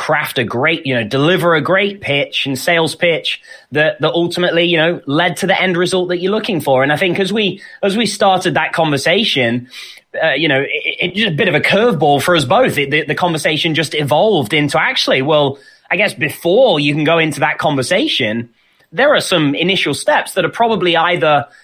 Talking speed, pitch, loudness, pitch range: 215 wpm, 160 Hz, -14 LUFS, 145-180 Hz